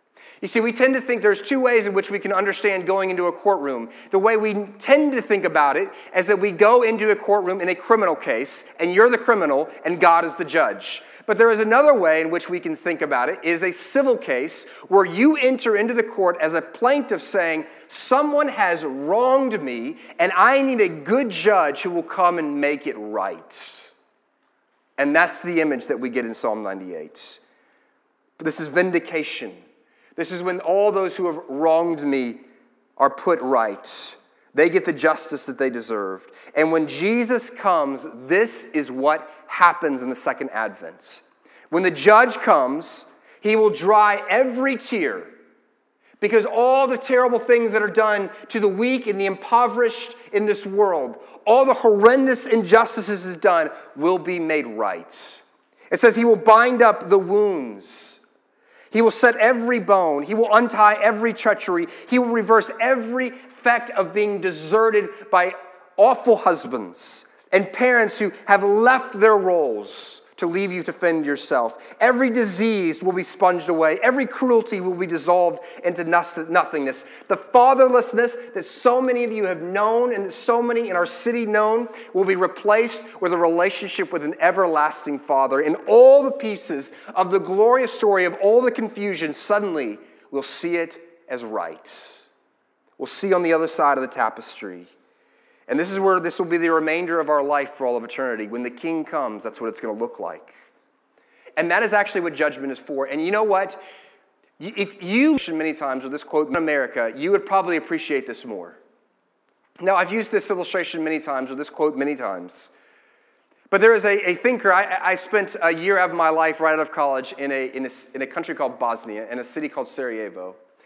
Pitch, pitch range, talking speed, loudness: 195 Hz, 165-235 Hz, 185 wpm, -20 LUFS